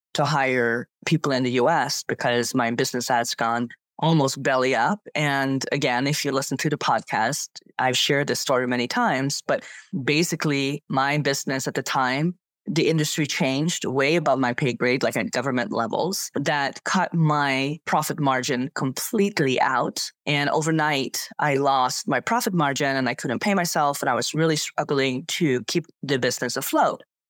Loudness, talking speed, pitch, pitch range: -23 LUFS, 165 wpm, 140 Hz, 130-155 Hz